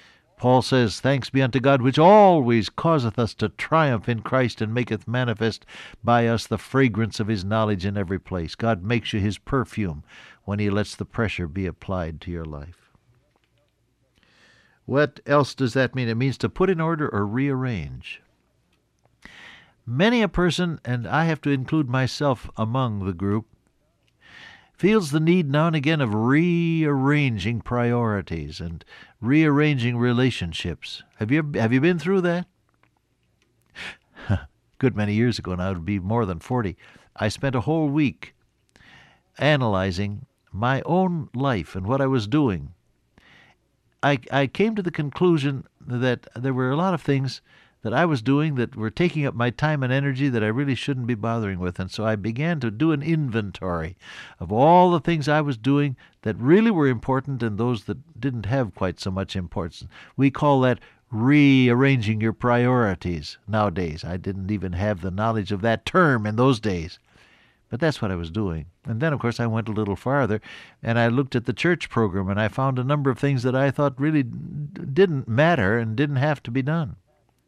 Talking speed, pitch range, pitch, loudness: 180 wpm, 105-145 Hz, 125 Hz, -23 LUFS